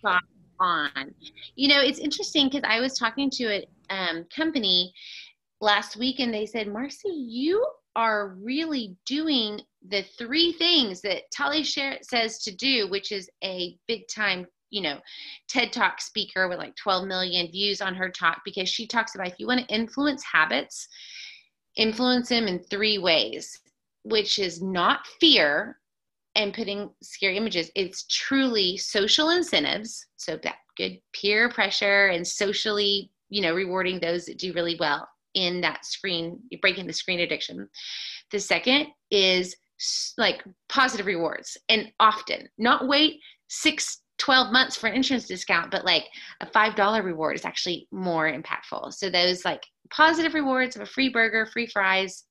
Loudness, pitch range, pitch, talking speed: -24 LUFS, 190-260 Hz, 210 Hz, 155 wpm